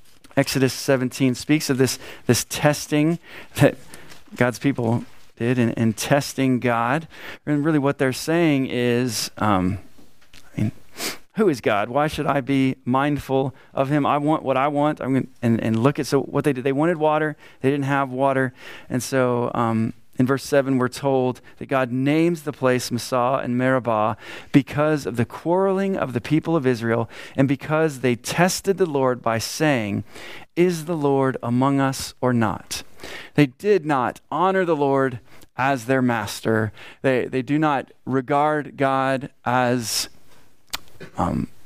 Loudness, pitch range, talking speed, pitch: -22 LUFS, 120-150 Hz, 165 wpm, 135 Hz